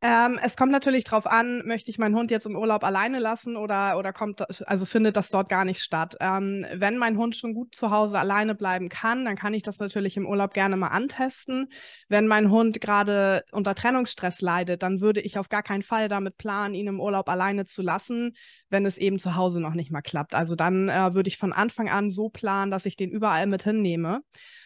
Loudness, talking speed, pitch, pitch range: -25 LUFS, 225 wpm, 205 Hz, 190-225 Hz